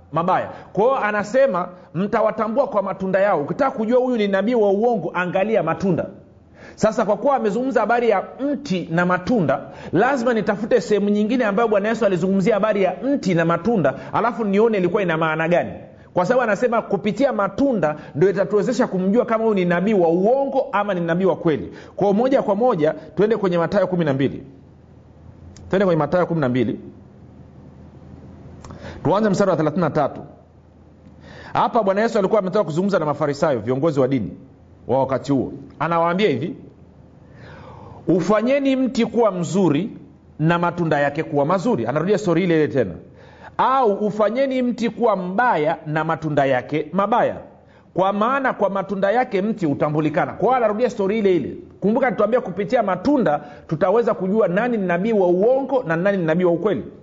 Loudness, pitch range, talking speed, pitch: -20 LUFS, 165-225 Hz, 155 wpm, 195 Hz